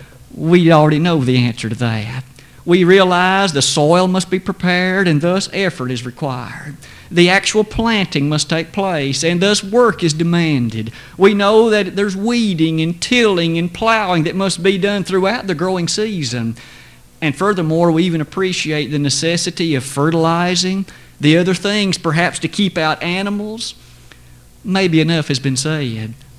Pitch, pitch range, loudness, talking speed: 170 Hz, 145-190 Hz, -15 LUFS, 155 wpm